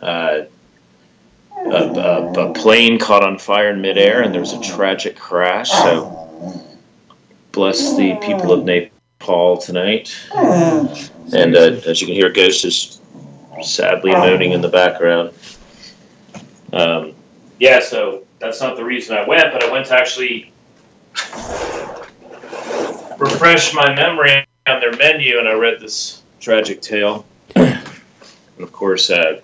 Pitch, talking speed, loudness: 120 Hz, 135 wpm, -14 LUFS